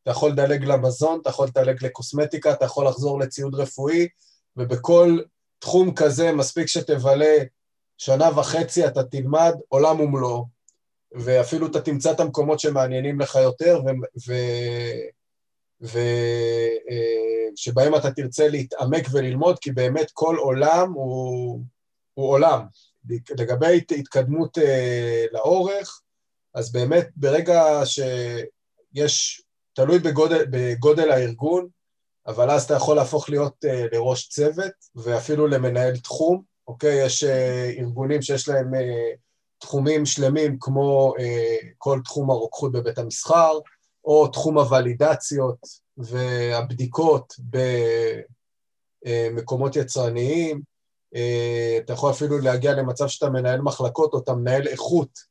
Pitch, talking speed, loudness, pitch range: 135 Hz, 115 wpm, -21 LUFS, 125-150 Hz